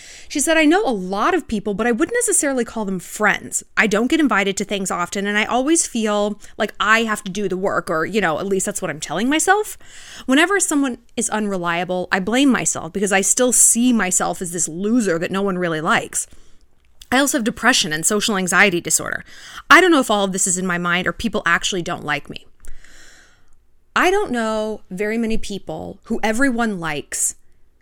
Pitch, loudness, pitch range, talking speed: 210 Hz, -18 LUFS, 185-240 Hz, 210 wpm